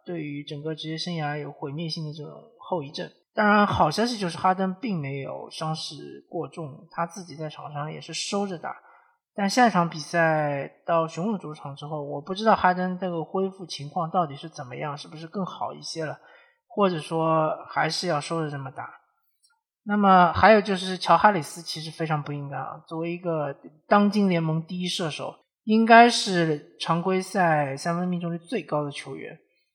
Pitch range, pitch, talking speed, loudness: 155-190 Hz, 170 Hz, 285 characters per minute, -25 LUFS